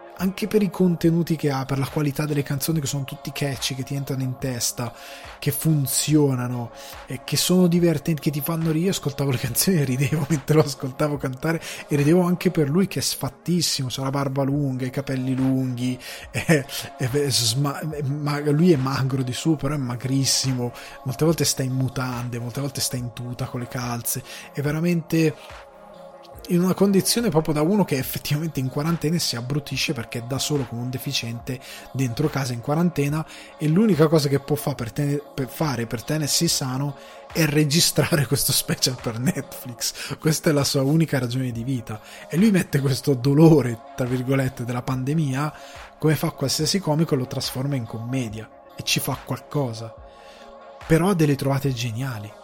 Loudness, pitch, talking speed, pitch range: -23 LUFS, 140 Hz, 180 wpm, 130-155 Hz